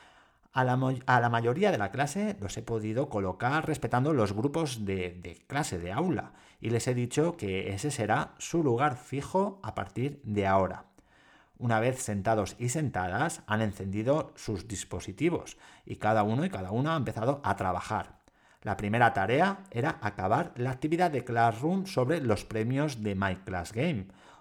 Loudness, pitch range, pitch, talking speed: -30 LUFS, 105-145 Hz, 115 Hz, 170 wpm